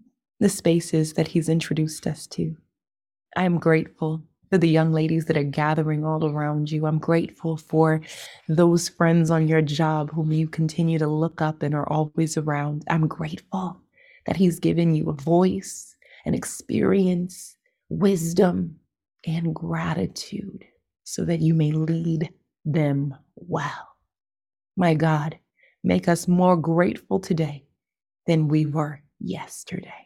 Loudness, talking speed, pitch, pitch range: -23 LUFS, 140 wpm, 160 Hz, 155-175 Hz